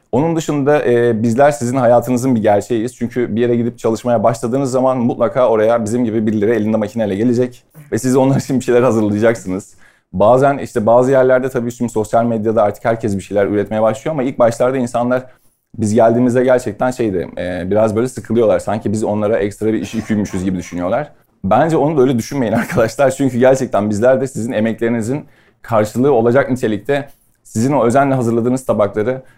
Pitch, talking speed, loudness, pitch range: 120 Hz, 175 wpm, -15 LUFS, 110-130 Hz